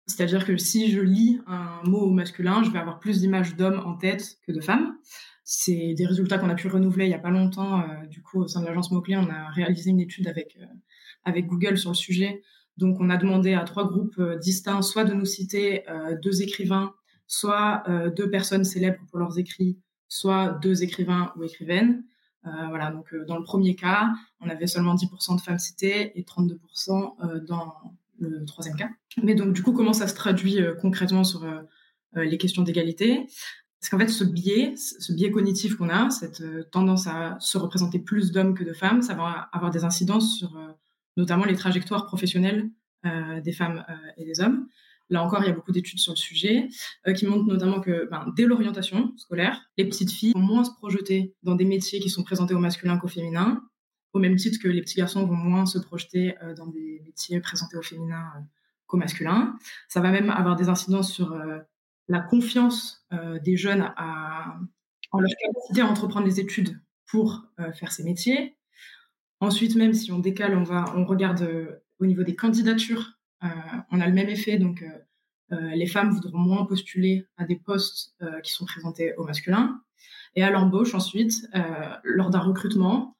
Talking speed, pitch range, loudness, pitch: 205 wpm, 175-205 Hz, -25 LUFS, 185 Hz